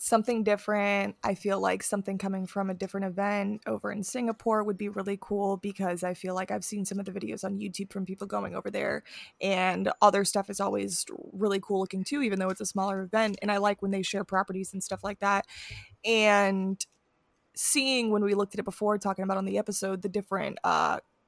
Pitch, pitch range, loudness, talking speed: 200 Hz, 190-205 Hz, -29 LUFS, 215 wpm